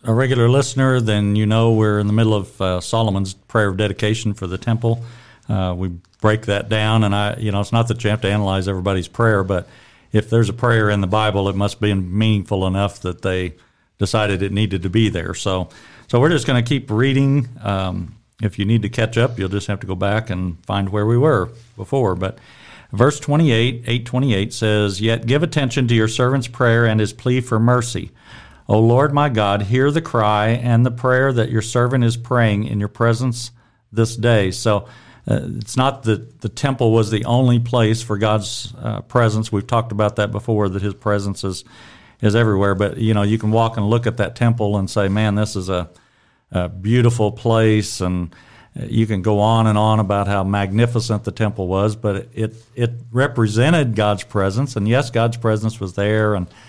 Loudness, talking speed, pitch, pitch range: -18 LUFS, 205 wpm, 110 Hz, 100-120 Hz